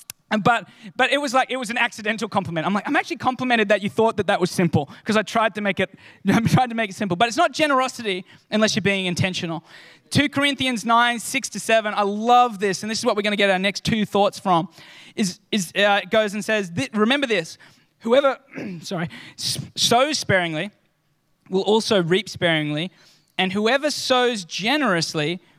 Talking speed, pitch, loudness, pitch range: 190 wpm, 210 Hz, -21 LUFS, 185-235 Hz